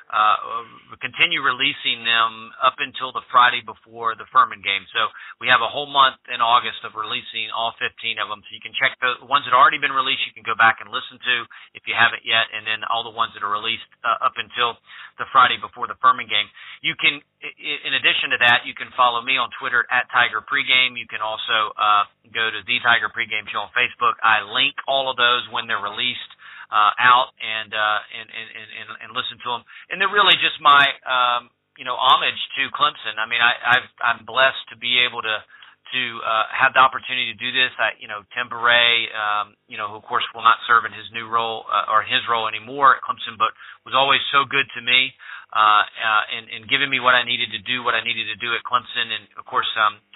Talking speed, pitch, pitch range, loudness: 230 wpm, 120 Hz, 110-125 Hz, -19 LUFS